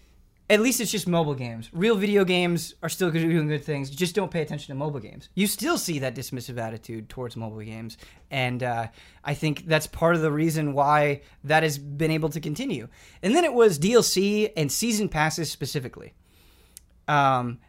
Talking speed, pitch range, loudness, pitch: 195 wpm, 135-180 Hz, -24 LUFS, 155 Hz